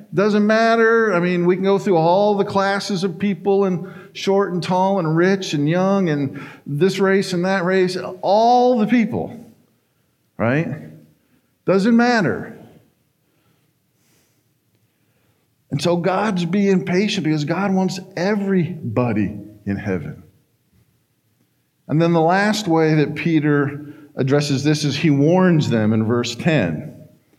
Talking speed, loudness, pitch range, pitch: 130 wpm, -18 LUFS, 150-195 Hz, 180 Hz